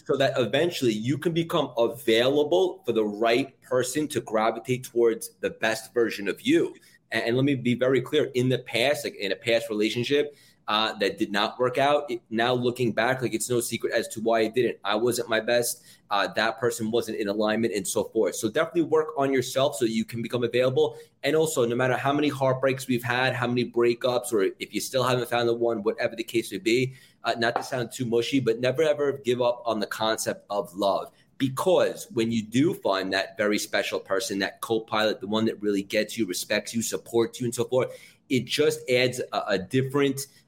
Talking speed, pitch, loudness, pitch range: 220 wpm, 120 Hz, -26 LUFS, 115-140 Hz